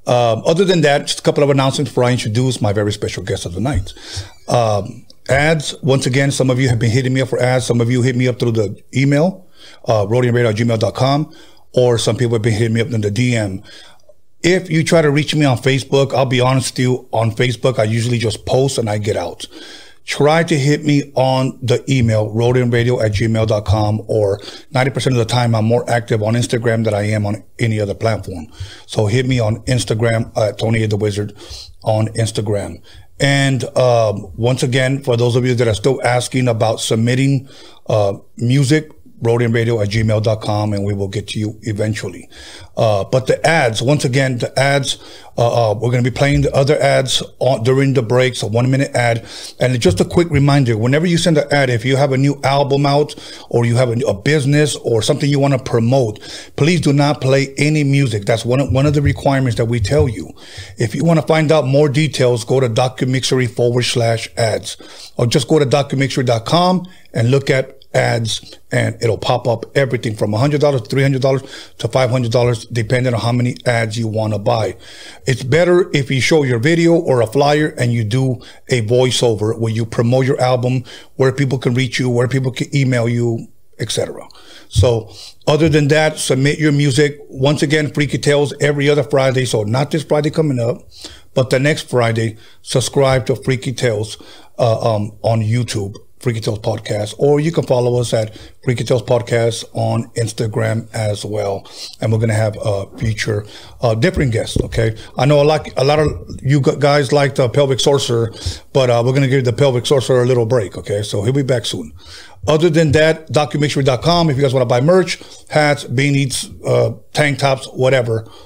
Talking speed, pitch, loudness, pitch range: 200 wpm, 125 Hz, -16 LUFS, 115-140 Hz